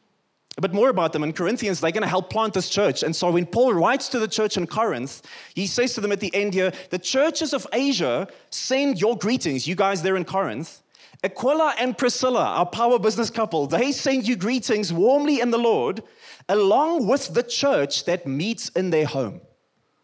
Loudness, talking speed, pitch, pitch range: -22 LUFS, 200 wpm, 215 Hz, 180-245 Hz